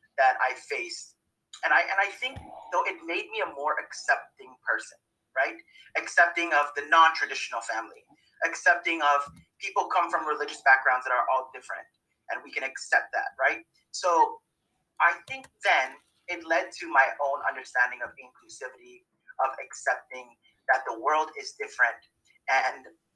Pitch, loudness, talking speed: 195 Hz, -26 LUFS, 160 wpm